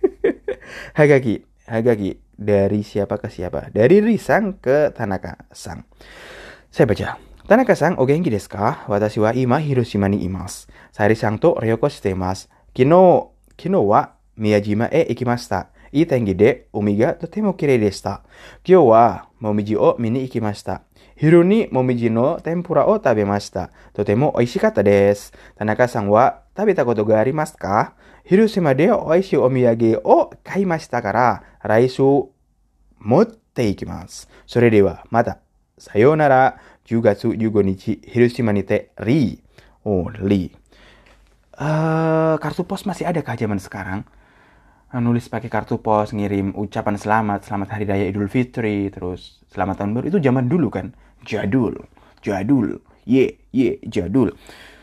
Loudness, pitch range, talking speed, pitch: -18 LUFS, 100-140 Hz, 200 wpm, 115 Hz